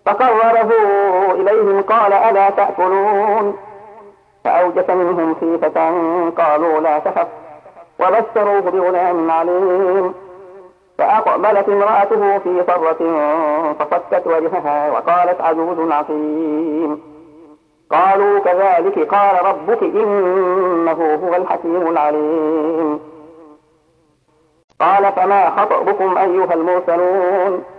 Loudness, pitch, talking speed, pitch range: -15 LUFS, 180 Hz, 80 wpm, 160-200 Hz